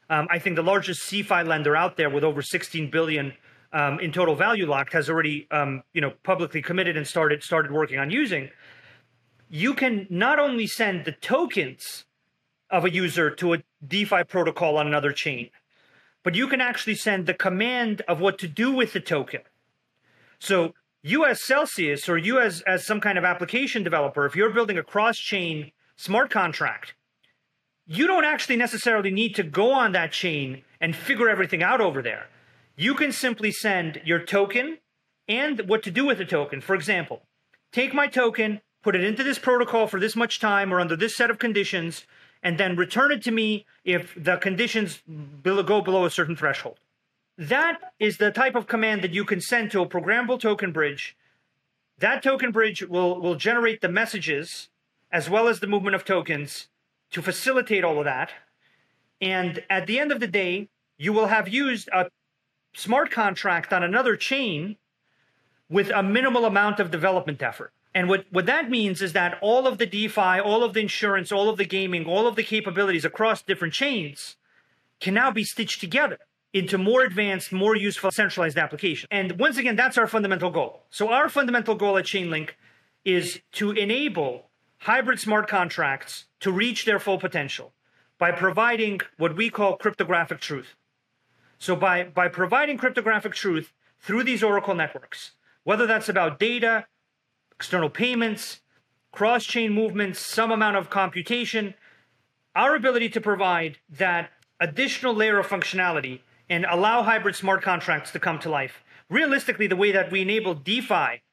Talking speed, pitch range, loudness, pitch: 175 wpm, 170-225 Hz, -23 LUFS, 195 Hz